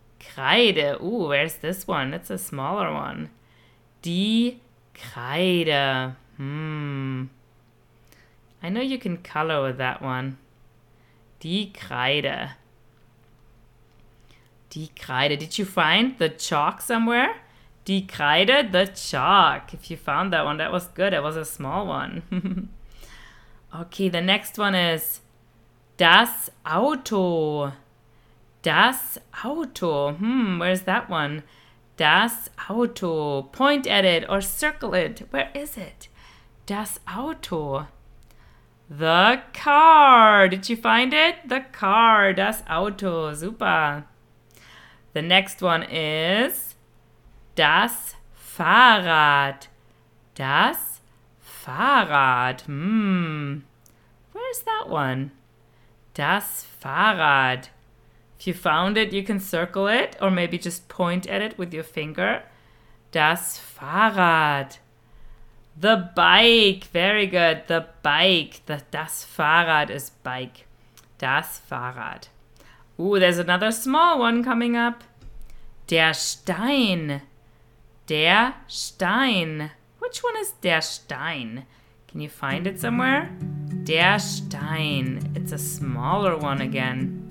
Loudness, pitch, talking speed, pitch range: -21 LUFS, 160 Hz, 110 wpm, 130-195 Hz